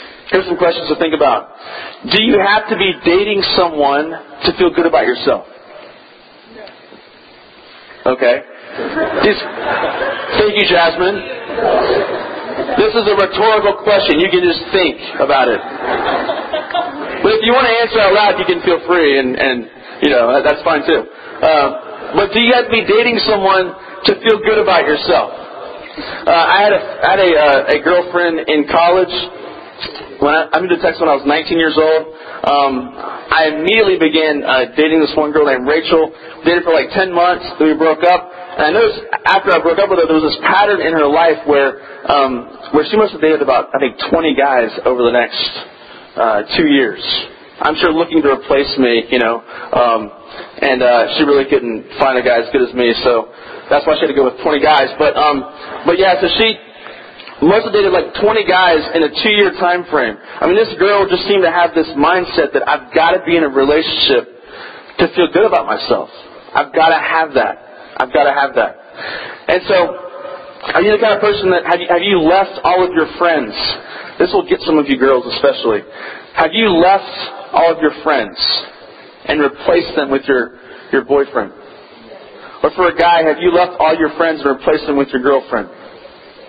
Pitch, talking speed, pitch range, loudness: 170 Hz, 195 wpm, 150-200 Hz, -13 LUFS